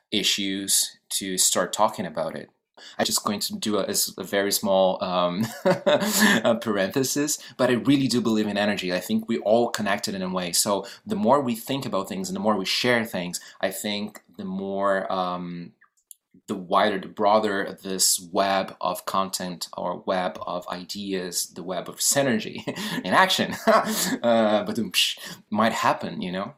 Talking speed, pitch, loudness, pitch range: 170 wpm, 100 Hz, -24 LUFS, 95-125 Hz